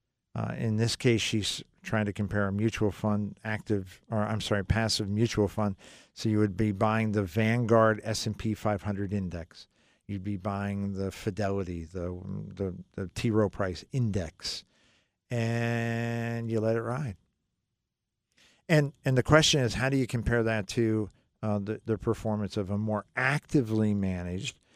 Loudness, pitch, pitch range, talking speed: -29 LUFS, 110 Hz, 100-115 Hz, 160 wpm